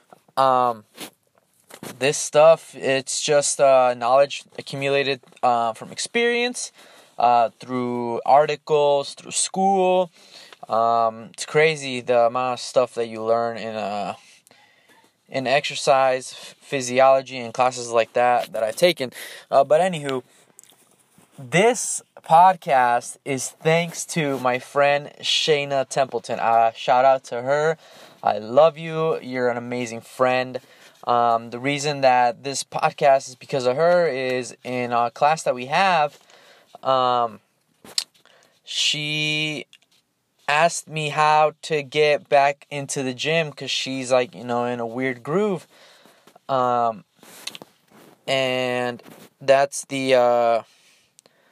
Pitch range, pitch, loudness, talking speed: 120-150 Hz, 135 Hz, -21 LUFS, 120 wpm